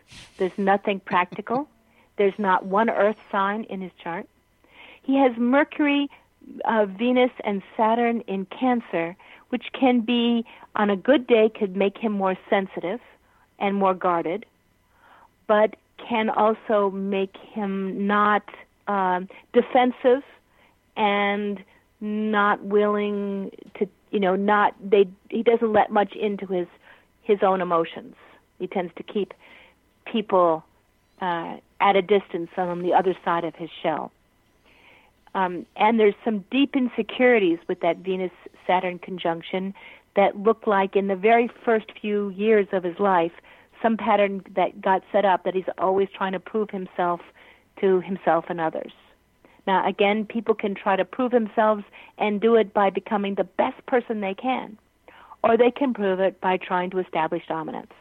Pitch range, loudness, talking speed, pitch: 185-225 Hz, -23 LUFS, 150 wpm, 200 Hz